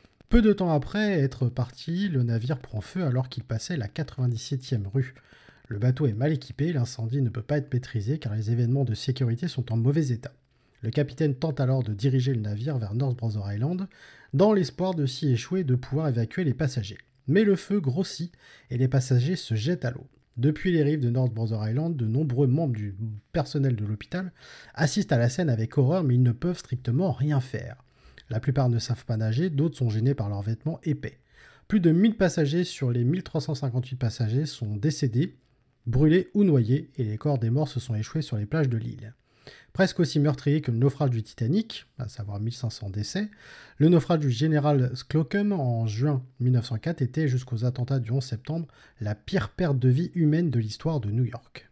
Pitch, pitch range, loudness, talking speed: 130 Hz, 120-155 Hz, -26 LUFS, 200 wpm